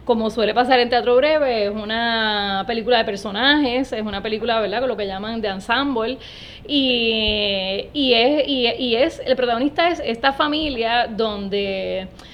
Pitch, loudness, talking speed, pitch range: 230 Hz, -19 LUFS, 160 wpm, 215-255 Hz